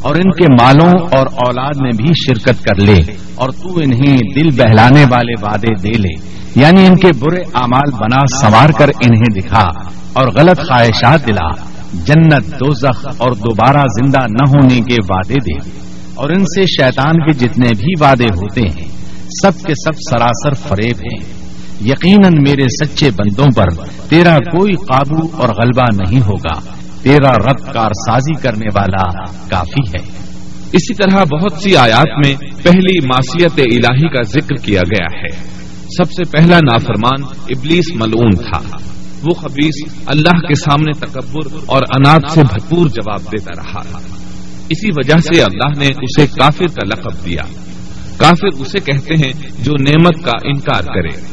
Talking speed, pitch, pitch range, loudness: 155 wpm, 130 Hz, 105-155 Hz, -11 LUFS